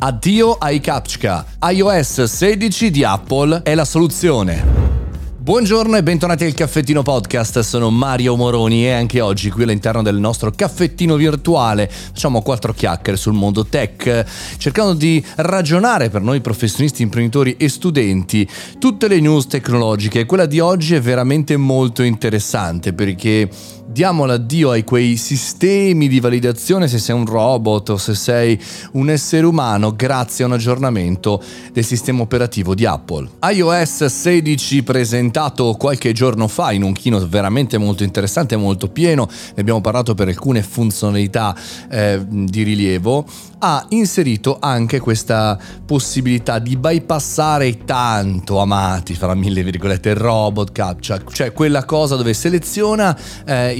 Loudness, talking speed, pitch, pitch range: -15 LUFS, 140 wpm, 120 Hz, 105-150 Hz